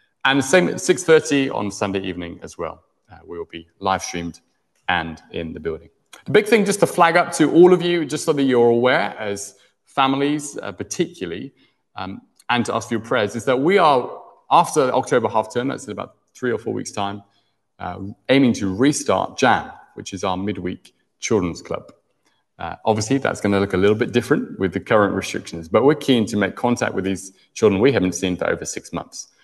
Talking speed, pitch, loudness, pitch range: 210 wpm, 110 Hz, -19 LUFS, 95-145 Hz